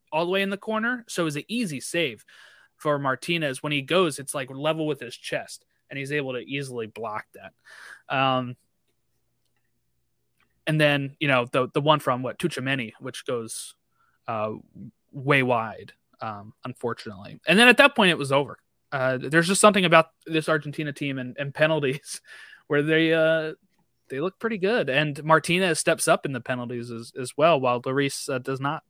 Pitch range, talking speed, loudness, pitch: 125-160 Hz, 185 wpm, -24 LUFS, 145 Hz